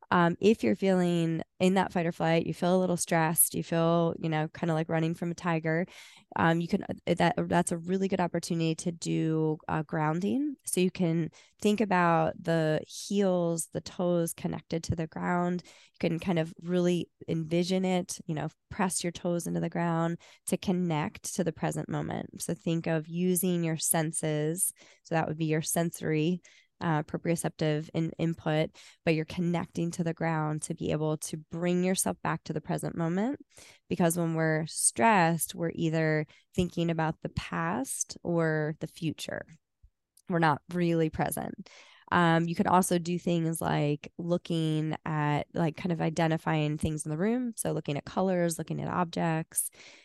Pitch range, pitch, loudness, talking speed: 160-180 Hz, 170 Hz, -30 LUFS, 175 wpm